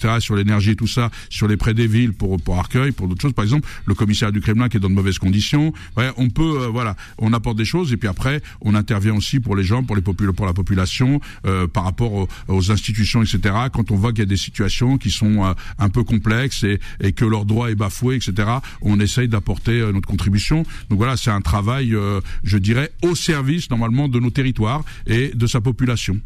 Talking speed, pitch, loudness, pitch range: 240 wpm, 110 Hz, -19 LUFS, 100-120 Hz